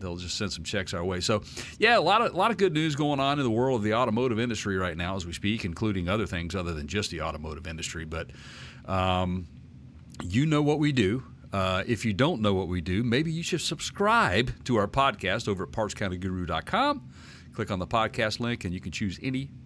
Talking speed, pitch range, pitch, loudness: 230 wpm, 90-125 Hz, 105 Hz, -27 LUFS